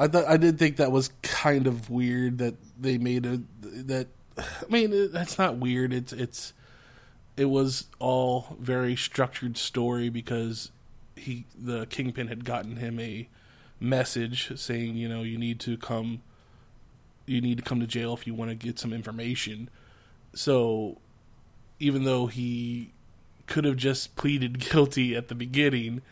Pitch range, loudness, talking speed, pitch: 115-130 Hz, -28 LUFS, 160 wpm, 125 Hz